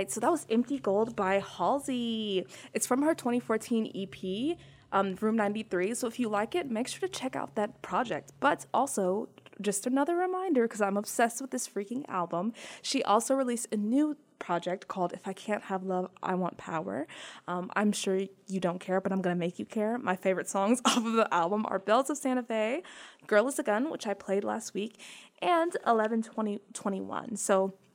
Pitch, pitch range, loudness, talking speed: 215 Hz, 195-245 Hz, -31 LUFS, 200 wpm